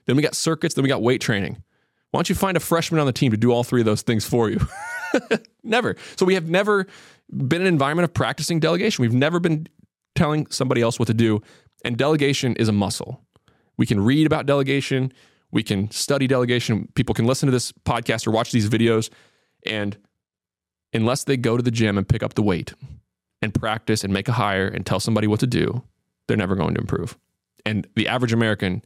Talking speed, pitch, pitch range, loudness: 220 wpm, 125 Hz, 110-155 Hz, -21 LUFS